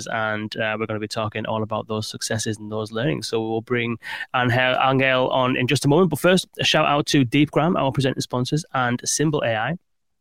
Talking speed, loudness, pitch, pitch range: 210 wpm, -21 LUFS, 125 Hz, 110-145 Hz